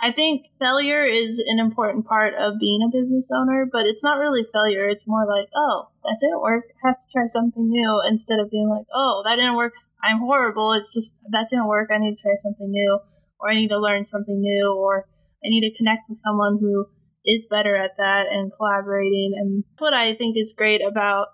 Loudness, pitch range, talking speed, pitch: -21 LUFS, 205-235 Hz, 220 wpm, 215 Hz